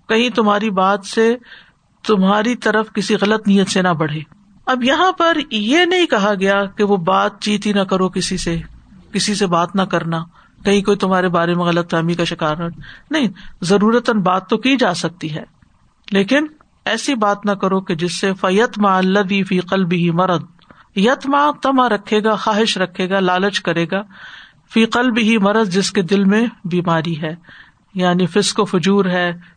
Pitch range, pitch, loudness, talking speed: 180-220 Hz, 200 Hz, -16 LUFS, 180 wpm